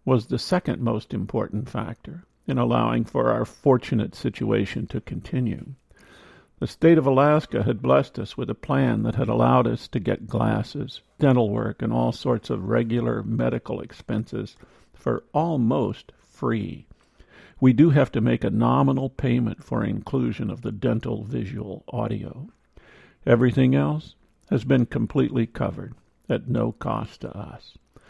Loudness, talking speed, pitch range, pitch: -24 LUFS, 145 wpm, 110-135 Hz, 120 Hz